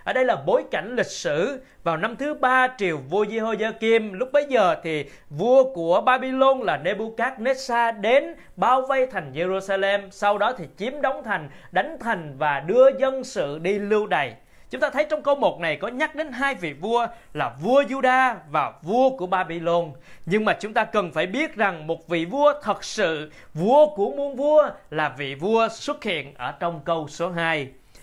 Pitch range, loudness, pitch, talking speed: 170-265 Hz, -23 LUFS, 220 Hz, 195 wpm